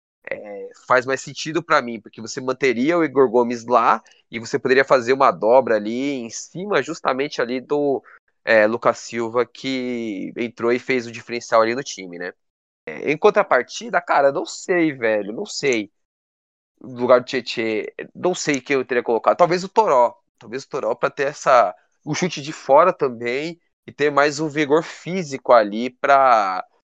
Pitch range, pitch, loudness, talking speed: 115-160 Hz, 135 Hz, -20 LUFS, 180 wpm